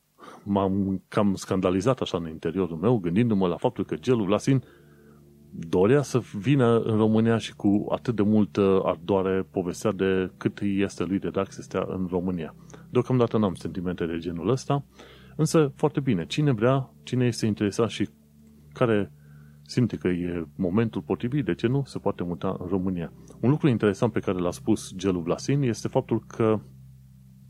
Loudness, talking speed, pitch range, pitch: -26 LUFS, 165 wpm, 90-120 Hz, 100 Hz